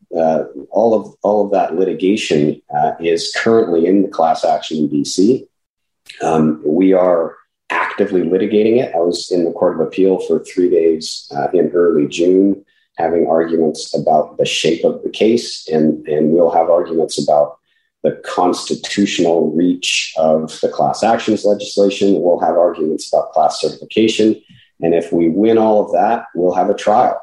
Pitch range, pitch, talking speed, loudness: 80-105 Hz, 95 Hz, 165 wpm, -15 LUFS